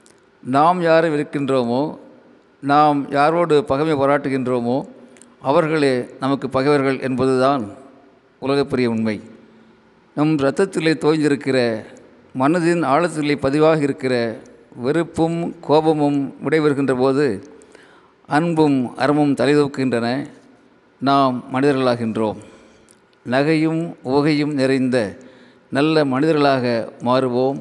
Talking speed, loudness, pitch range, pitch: 75 wpm, -18 LUFS, 130-150 Hz, 140 Hz